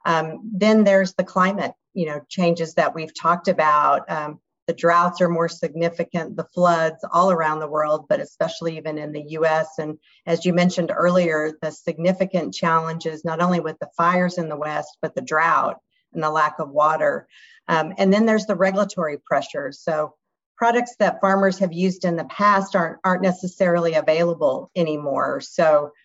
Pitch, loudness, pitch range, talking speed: 170 Hz, -21 LUFS, 155-185 Hz, 175 wpm